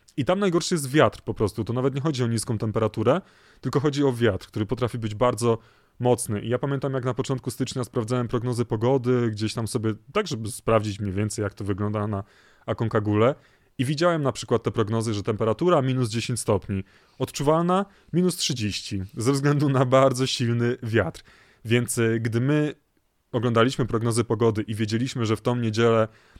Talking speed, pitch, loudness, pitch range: 175 wpm, 120 Hz, -24 LUFS, 110-135 Hz